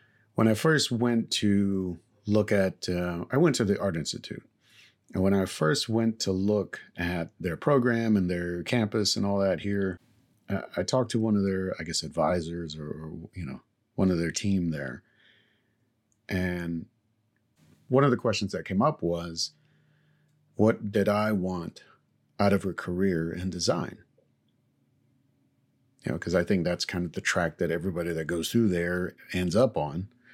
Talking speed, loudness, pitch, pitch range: 170 wpm, -28 LUFS, 100 Hz, 90-115 Hz